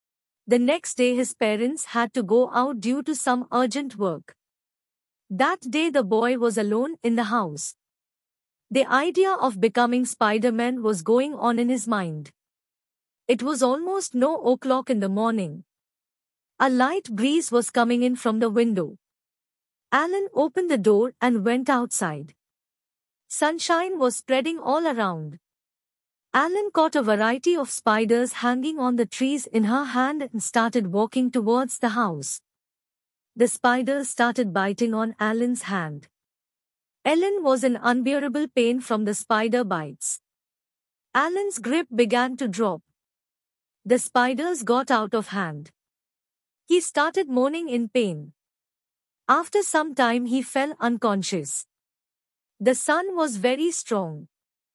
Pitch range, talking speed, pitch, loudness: 215-270 Hz, 135 wpm, 245 Hz, -23 LUFS